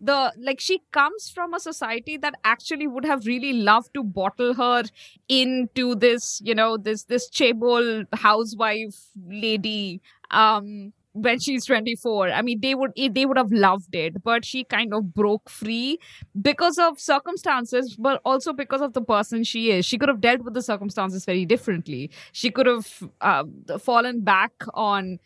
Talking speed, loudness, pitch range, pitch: 170 wpm, -22 LUFS, 210-265 Hz, 235 Hz